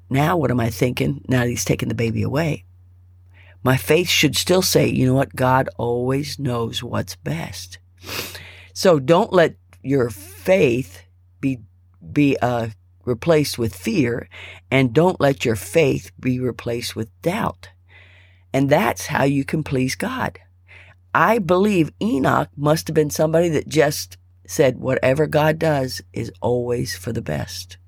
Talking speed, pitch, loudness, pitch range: 150 wpm, 120 Hz, -20 LUFS, 95-145 Hz